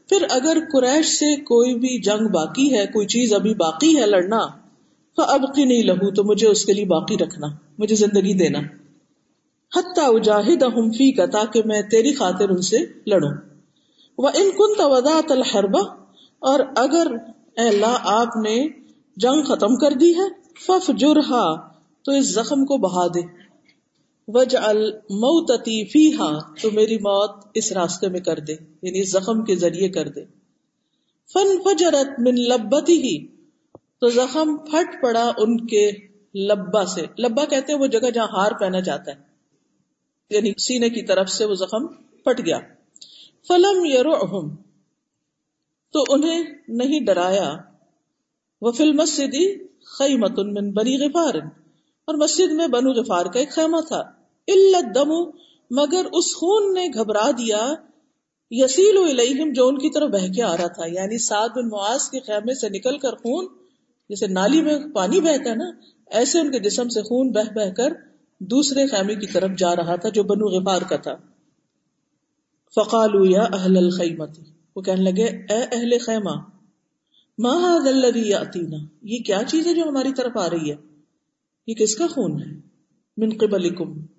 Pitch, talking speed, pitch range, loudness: 235 Hz, 160 wpm, 200-290 Hz, -19 LUFS